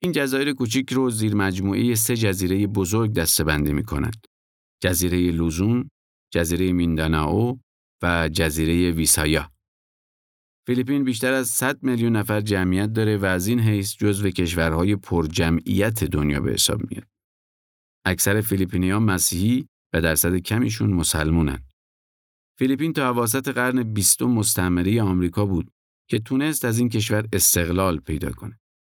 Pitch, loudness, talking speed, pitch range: 100 Hz, -21 LUFS, 135 wpm, 85-115 Hz